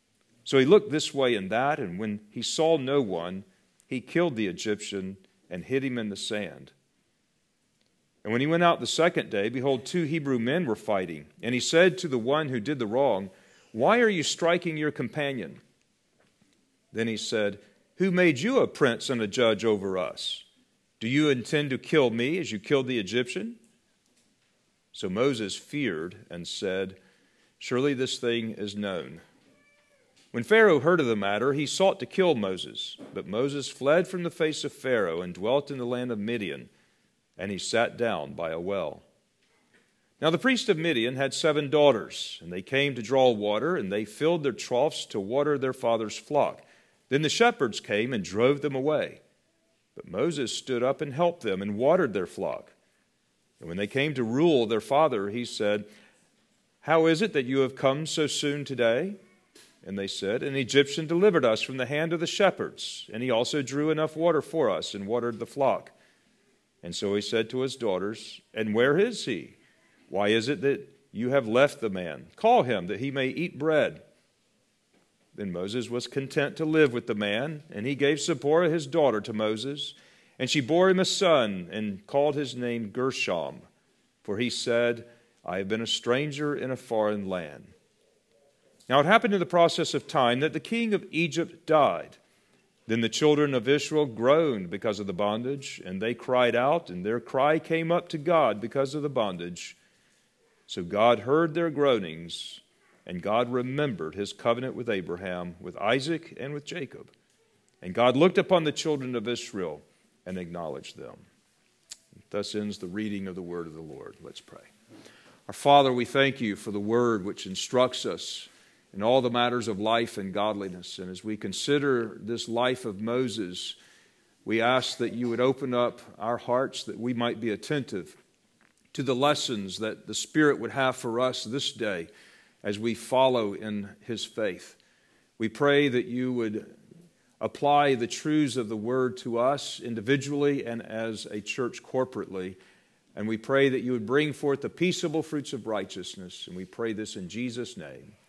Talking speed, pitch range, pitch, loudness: 185 wpm, 110-150 Hz, 125 Hz, -27 LUFS